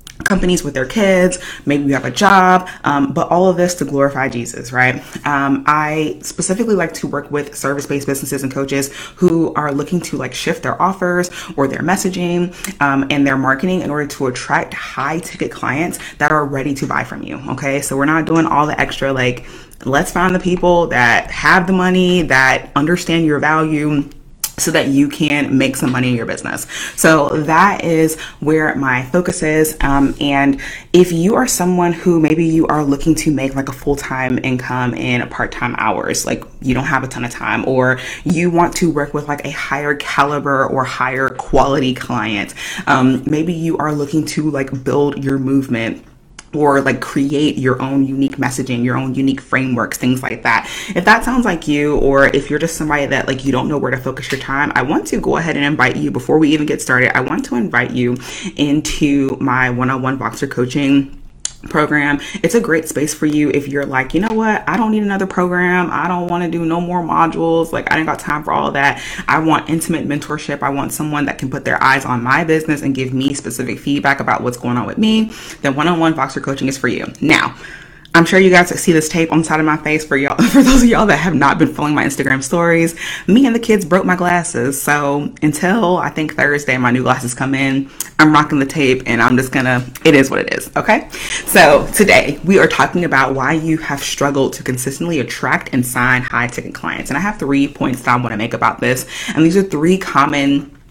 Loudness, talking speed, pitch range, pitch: -15 LUFS, 220 wpm, 135-165 Hz, 145 Hz